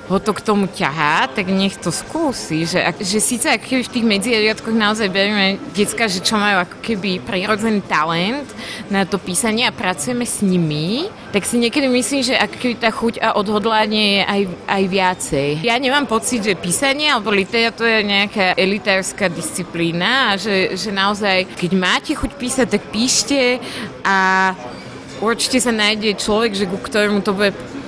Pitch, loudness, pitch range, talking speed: 210 Hz, -17 LUFS, 190-230 Hz, 170 wpm